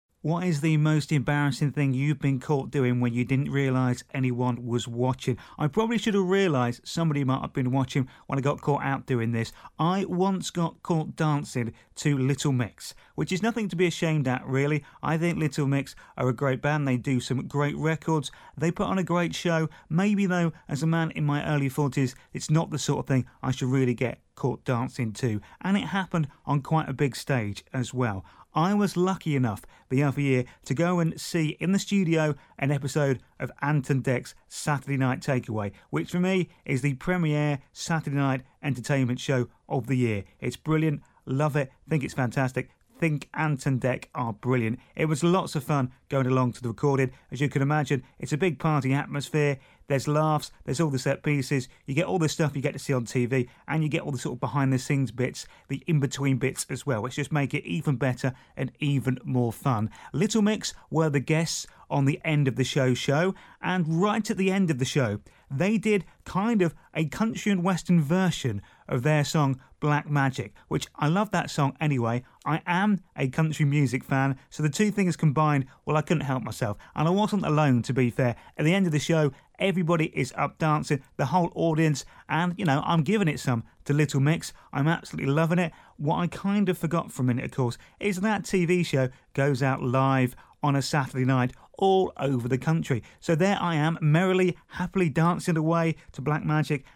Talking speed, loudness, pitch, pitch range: 210 wpm, -27 LUFS, 145 Hz, 130-165 Hz